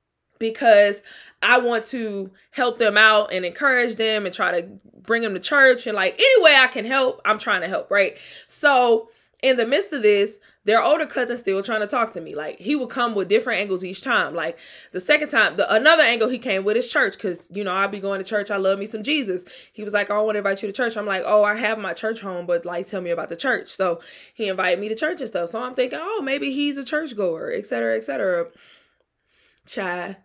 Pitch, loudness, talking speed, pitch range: 220 Hz, -20 LUFS, 250 wpm, 195-255 Hz